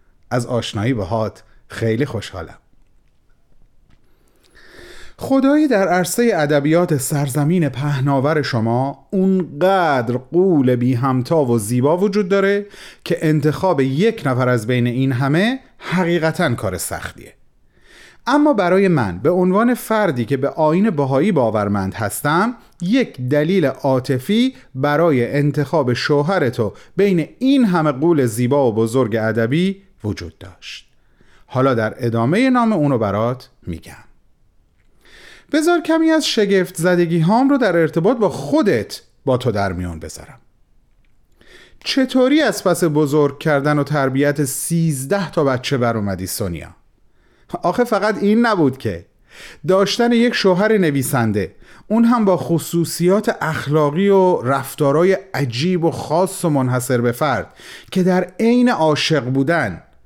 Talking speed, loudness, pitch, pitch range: 125 wpm, -17 LUFS, 150 Hz, 125-190 Hz